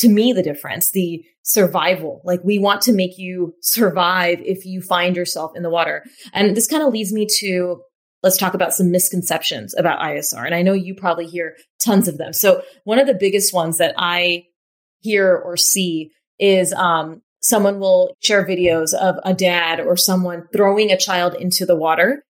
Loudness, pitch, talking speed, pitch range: -17 LUFS, 185 Hz, 190 wpm, 175-200 Hz